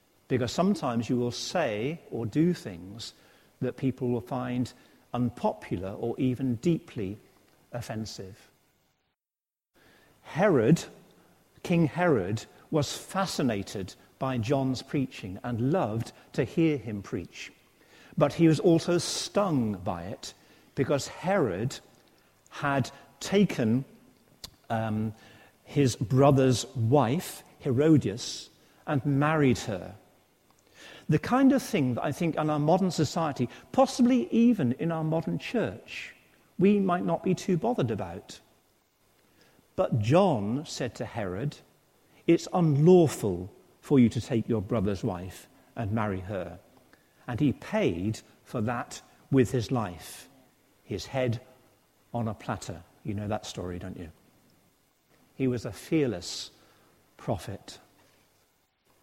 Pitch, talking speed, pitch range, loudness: 130 Hz, 115 wpm, 115-155 Hz, -28 LUFS